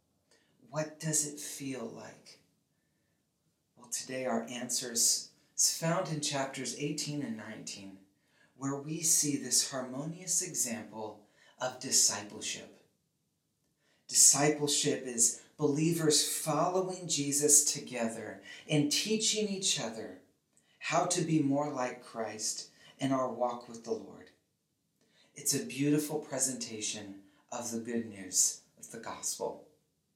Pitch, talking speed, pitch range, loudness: 140 Hz, 115 wpm, 120-150 Hz, -31 LUFS